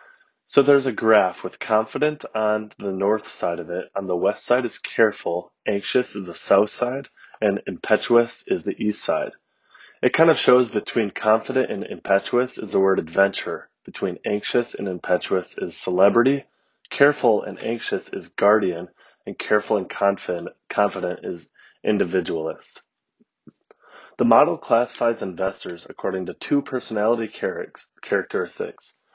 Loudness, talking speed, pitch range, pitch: -22 LUFS, 140 wpm, 100-130 Hz, 110 Hz